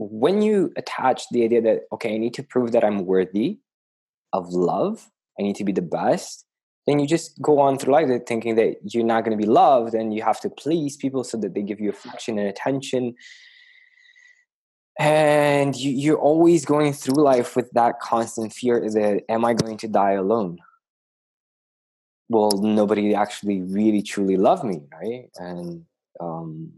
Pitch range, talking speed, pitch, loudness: 105-145 Hz, 175 wpm, 115 Hz, -21 LUFS